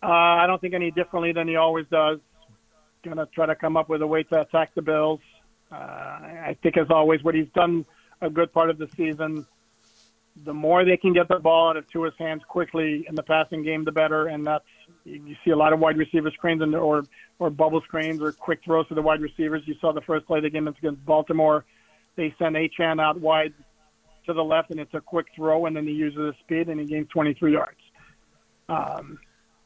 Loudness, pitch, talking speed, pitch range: -23 LUFS, 160 Hz, 225 wpm, 155-165 Hz